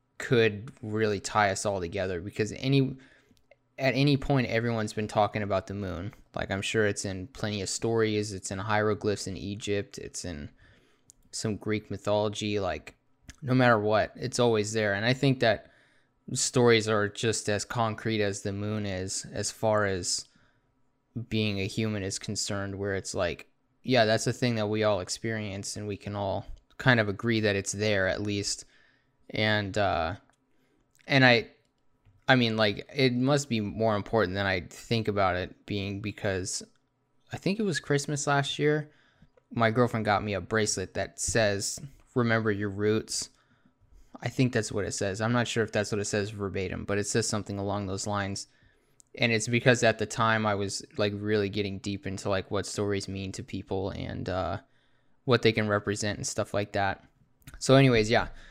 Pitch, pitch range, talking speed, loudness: 105 Hz, 100-120 Hz, 180 wpm, -28 LUFS